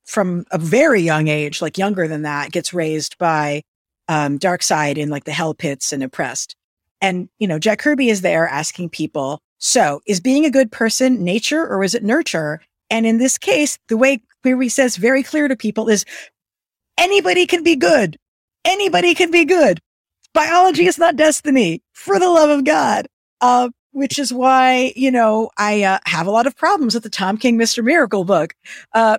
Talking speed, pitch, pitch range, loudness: 190 wpm, 225 Hz, 170-275 Hz, -16 LUFS